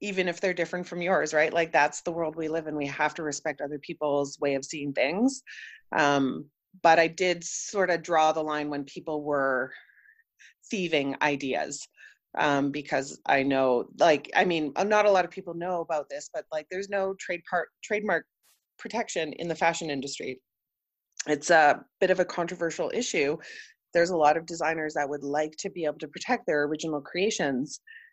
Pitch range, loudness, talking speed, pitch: 150-190 Hz, -27 LUFS, 190 wpm, 165 Hz